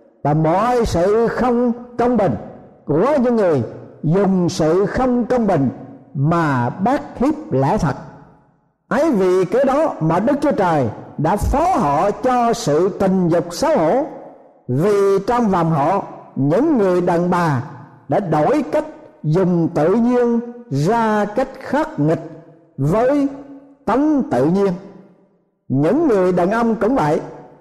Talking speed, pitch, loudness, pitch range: 140 wpm, 195 Hz, -17 LUFS, 160-245 Hz